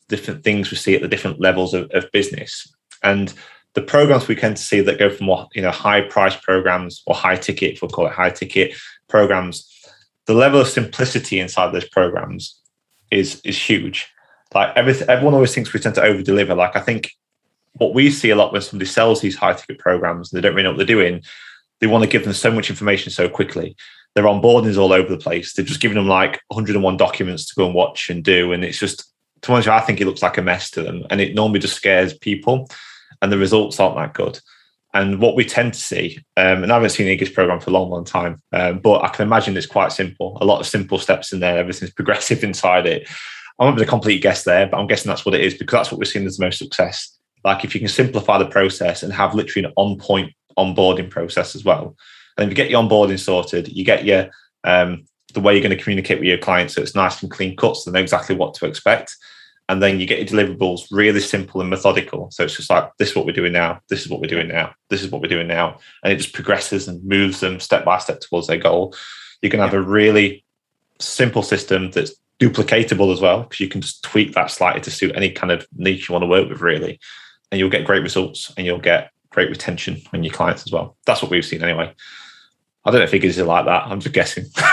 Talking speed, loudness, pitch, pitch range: 245 wpm, -17 LUFS, 100 Hz, 95-110 Hz